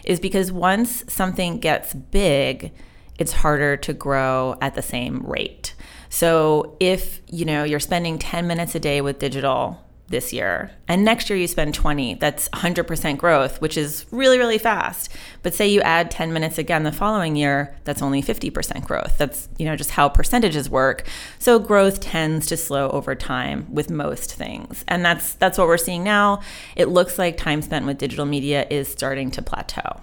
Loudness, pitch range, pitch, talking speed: -21 LUFS, 140-185 Hz, 160 Hz, 185 wpm